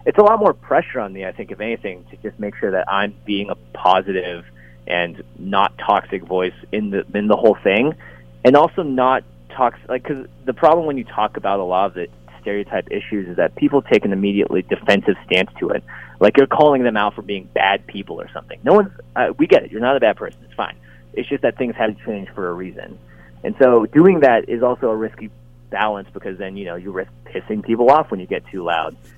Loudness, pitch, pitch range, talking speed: -18 LUFS, 100 Hz, 90-120 Hz, 235 wpm